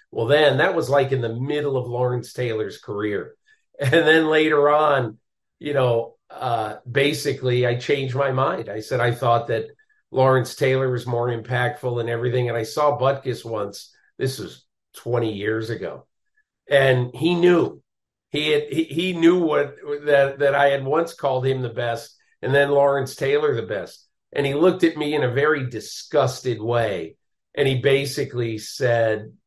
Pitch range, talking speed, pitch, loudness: 120-150 Hz, 170 wpm, 135 Hz, -21 LUFS